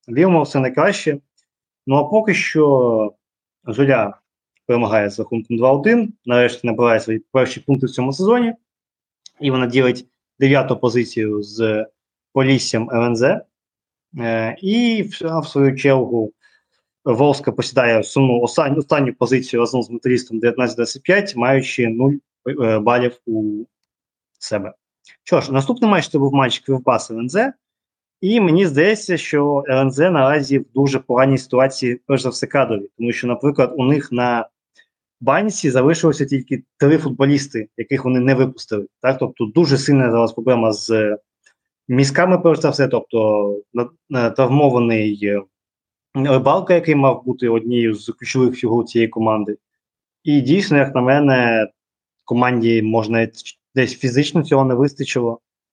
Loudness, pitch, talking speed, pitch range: -17 LUFS, 130 Hz, 130 wpm, 115-145 Hz